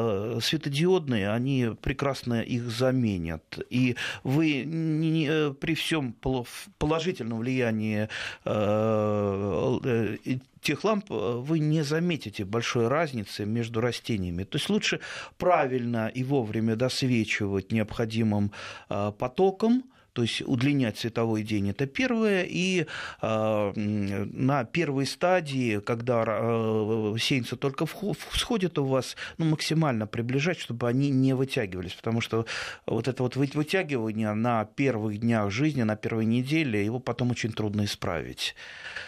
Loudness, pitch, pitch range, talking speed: -28 LUFS, 120 Hz, 110-145 Hz, 115 wpm